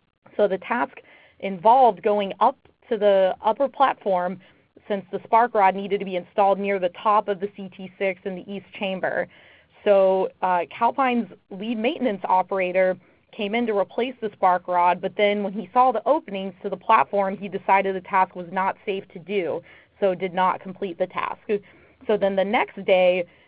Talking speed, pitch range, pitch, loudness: 180 wpm, 190-215 Hz, 195 Hz, -23 LUFS